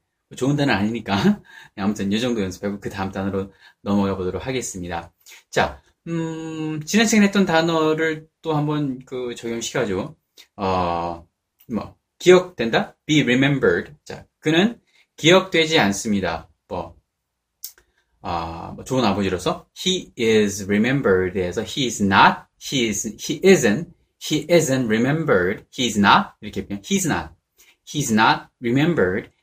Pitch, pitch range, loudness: 120 Hz, 100-160 Hz, -20 LUFS